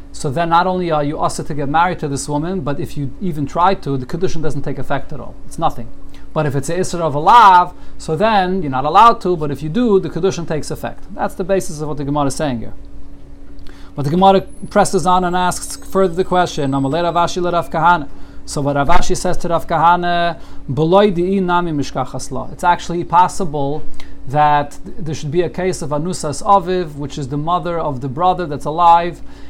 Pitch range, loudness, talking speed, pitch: 145-180 Hz, -16 LUFS, 195 wpm, 165 Hz